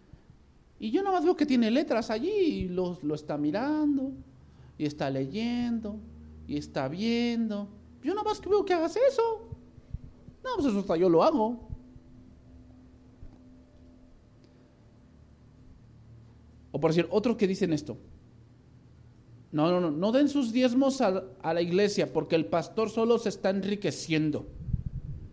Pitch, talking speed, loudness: 190 Hz, 140 wpm, -28 LUFS